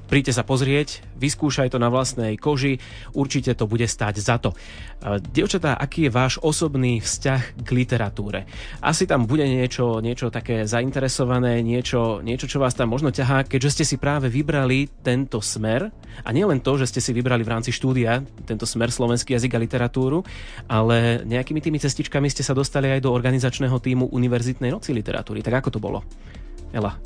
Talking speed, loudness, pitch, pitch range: 175 wpm, -22 LUFS, 125 Hz, 115-135 Hz